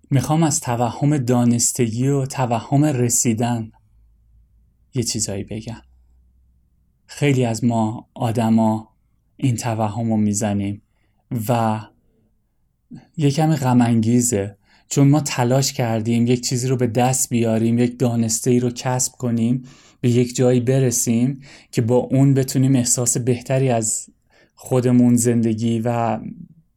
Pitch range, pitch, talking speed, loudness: 110-130 Hz, 120 Hz, 120 wpm, -19 LUFS